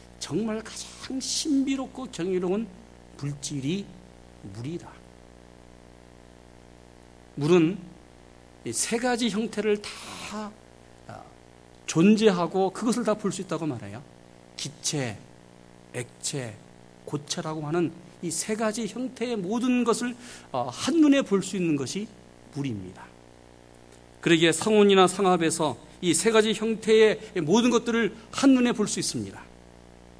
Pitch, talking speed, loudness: 165 Hz, 220 characters per minute, -25 LUFS